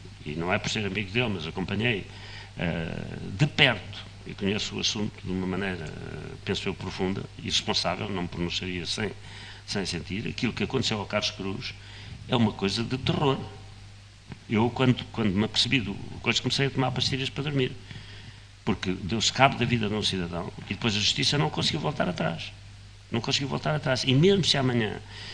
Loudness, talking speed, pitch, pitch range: -27 LUFS, 180 wpm, 105 Hz, 100-120 Hz